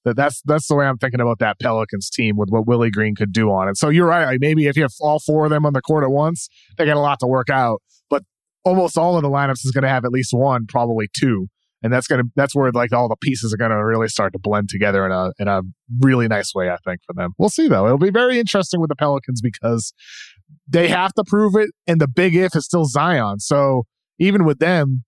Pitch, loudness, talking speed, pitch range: 135 Hz, -18 LUFS, 275 wpm, 115-155 Hz